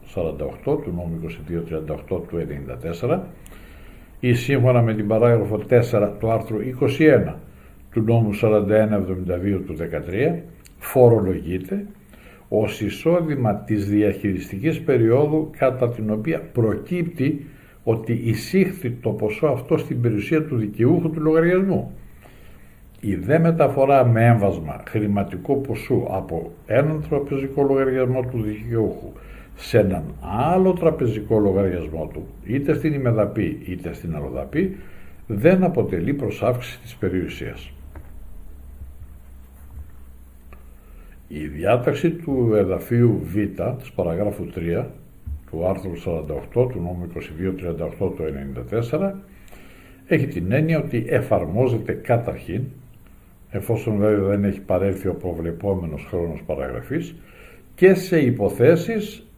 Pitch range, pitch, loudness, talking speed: 85-130 Hz, 105 Hz, -21 LUFS, 105 wpm